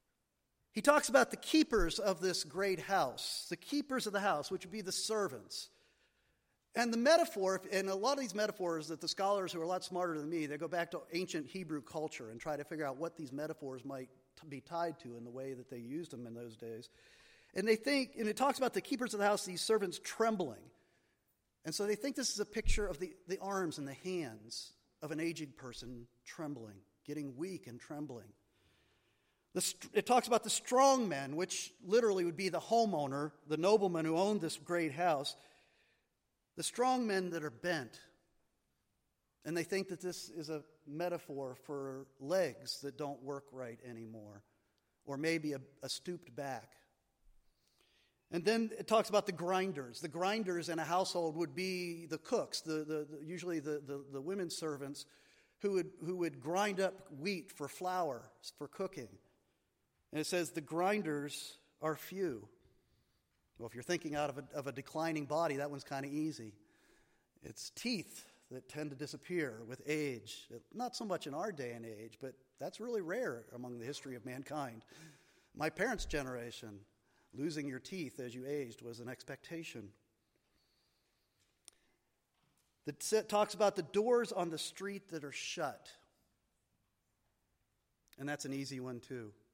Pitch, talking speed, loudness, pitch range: 160 Hz, 180 wpm, -38 LUFS, 135-190 Hz